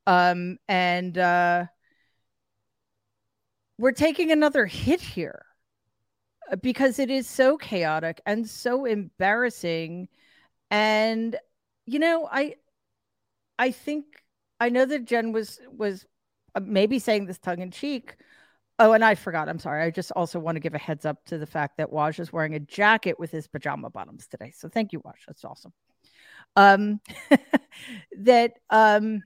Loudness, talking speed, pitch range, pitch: -24 LUFS, 145 wpm, 165-240 Hz, 195 Hz